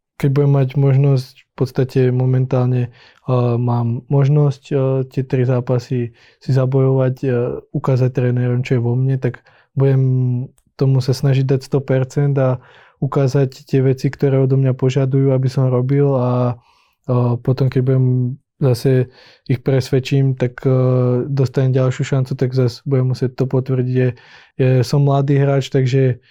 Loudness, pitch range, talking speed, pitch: -17 LUFS, 125-135 Hz, 150 wpm, 130 Hz